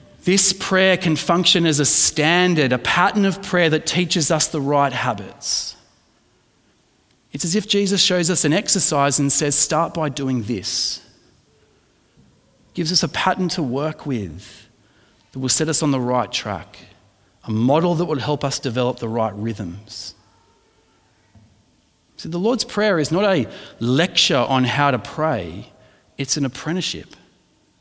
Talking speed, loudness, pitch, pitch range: 155 wpm, -18 LUFS, 145 Hz, 120-175 Hz